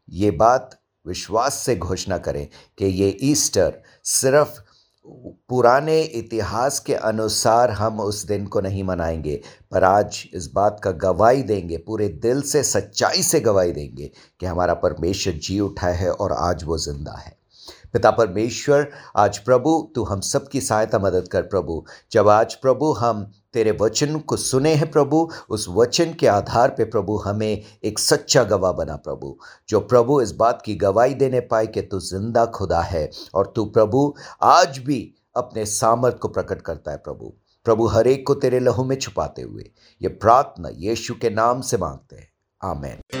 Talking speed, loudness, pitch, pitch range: 170 wpm, -20 LUFS, 110 Hz, 95-130 Hz